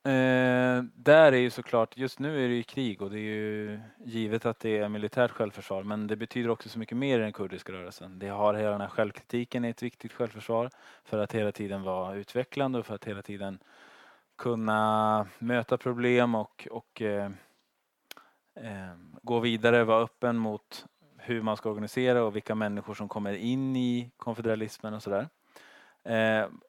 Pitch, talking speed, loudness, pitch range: 110 Hz, 185 wpm, -29 LUFS, 105-120 Hz